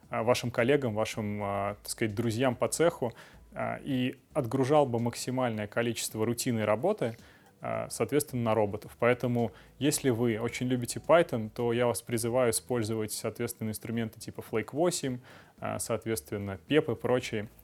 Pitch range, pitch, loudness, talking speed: 110-125 Hz, 120 Hz, -30 LUFS, 125 wpm